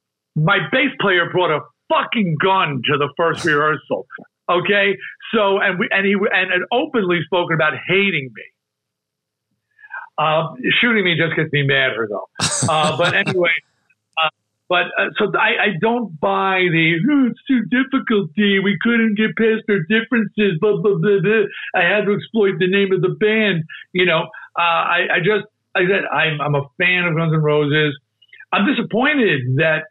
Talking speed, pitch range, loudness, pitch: 170 wpm, 160-215 Hz, -17 LUFS, 190 Hz